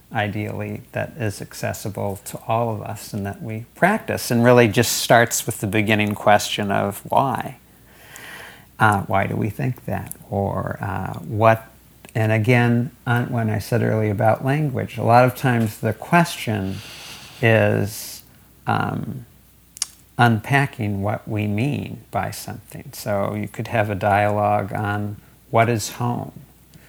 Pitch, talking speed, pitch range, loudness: 110 Hz, 140 wpm, 105-120 Hz, -21 LUFS